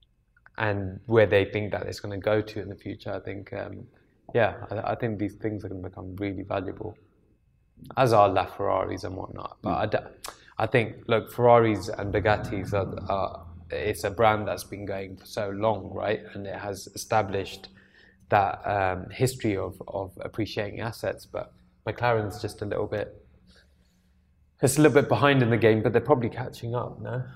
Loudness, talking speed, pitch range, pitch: -27 LUFS, 180 wpm, 95-110 Hz, 105 Hz